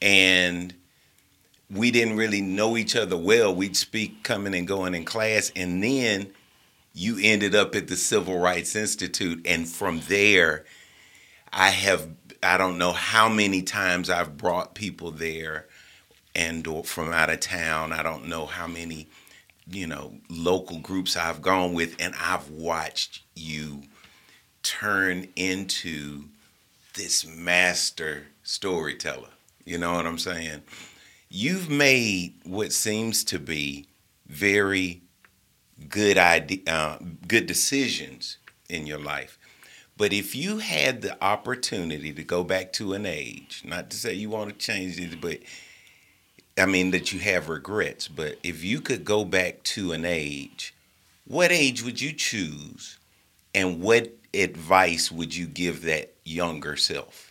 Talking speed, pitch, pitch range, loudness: 145 wpm, 90 Hz, 80-100 Hz, -24 LUFS